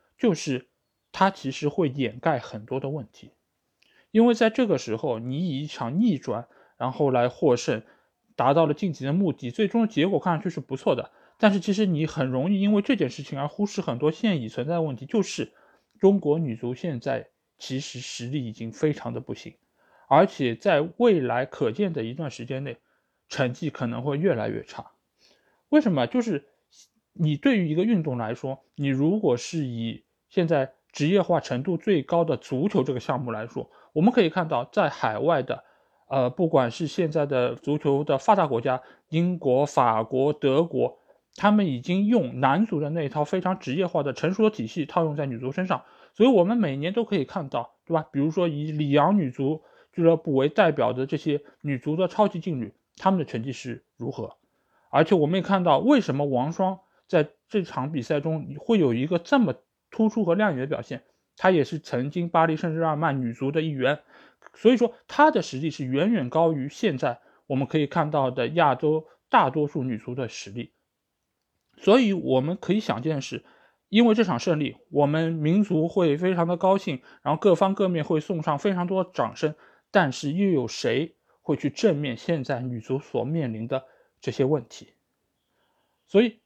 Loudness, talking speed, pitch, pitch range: -25 LUFS, 280 characters per minute, 155 Hz, 135-190 Hz